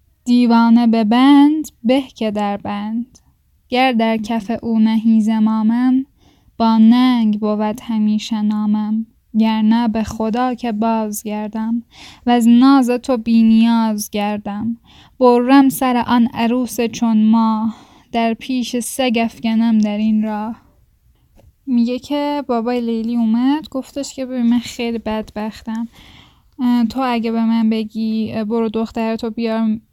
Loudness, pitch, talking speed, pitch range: -16 LUFS, 230 Hz, 130 wpm, 220-245 Hz